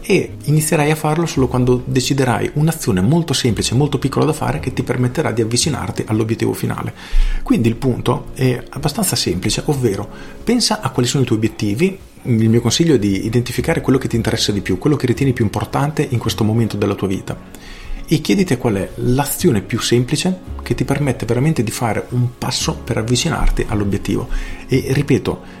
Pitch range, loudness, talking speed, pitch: 110-140 Hz, -17 LUFS, 185 wpm, 125 Hz